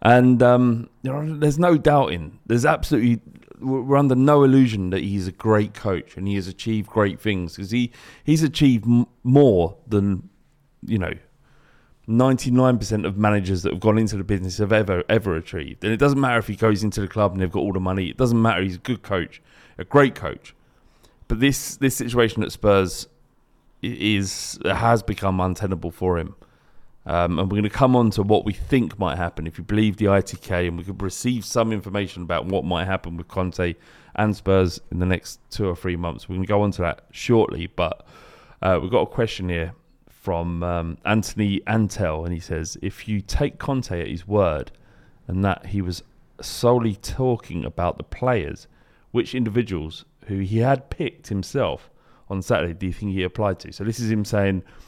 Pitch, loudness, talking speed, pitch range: 105 Hz, -22 LUFS, 195 wpm, 90-120 Hz